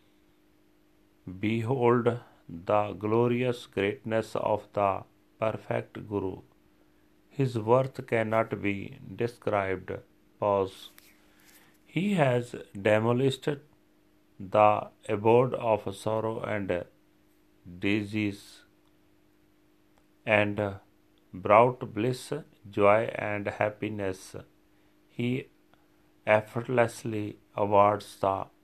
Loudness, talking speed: -28 LUFS, 70 wpm